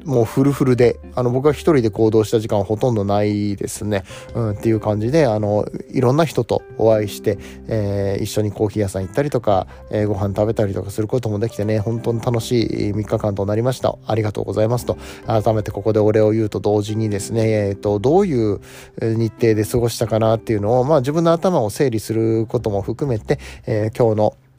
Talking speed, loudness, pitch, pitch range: 430 characters per minute, -19 LUFS, 110 Hz, 105-120 Hz